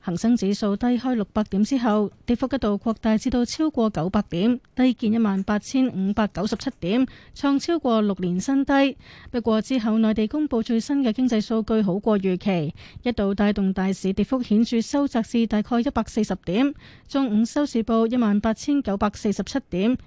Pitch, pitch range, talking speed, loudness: 225 Hz, 205-255 Hz, 290 characters per minute, -23 LUFS